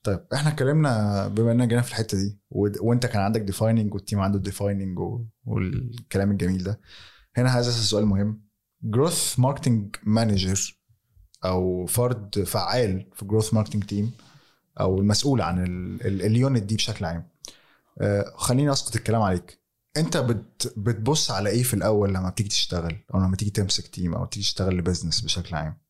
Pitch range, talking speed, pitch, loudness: 95-120 Hz, 150 wpm, 105 Hz, -24 LUFS